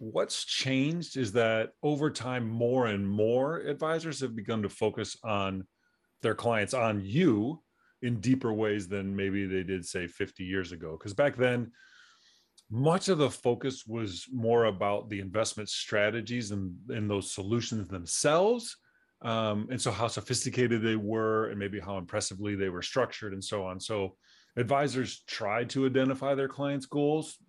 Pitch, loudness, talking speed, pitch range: 115 Hz, -31 LUFS, 160 wpm, 100-130 Hz